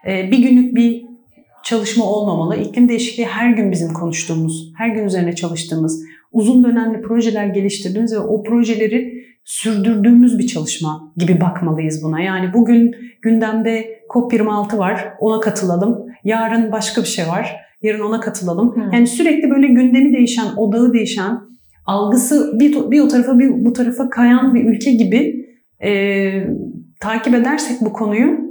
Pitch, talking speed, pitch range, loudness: 225 Hz, 140 wpm, 200-240 Hz, -15 LUFS